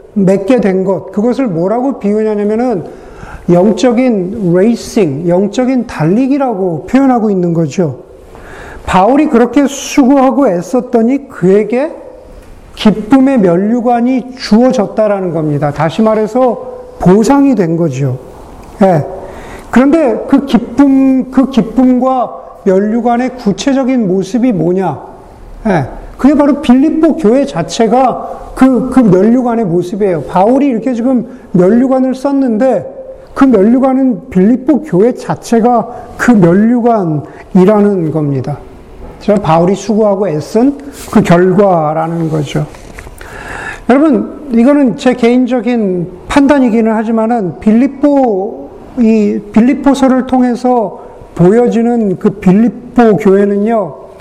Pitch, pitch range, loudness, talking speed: 235 Hz, 190-255 Hz, -10 LUFS, 255 characters per minute